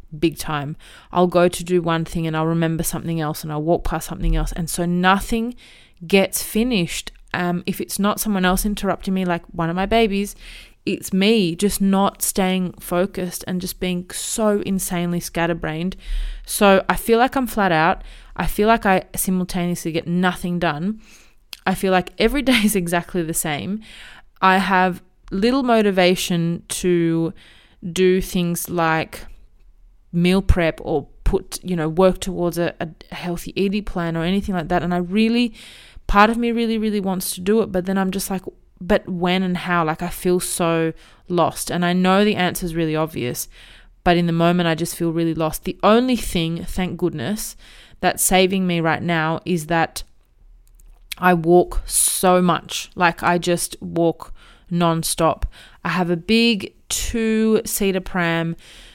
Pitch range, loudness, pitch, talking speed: 170-195 Hz, -20 LUFS, 180 Hz, 170 wpm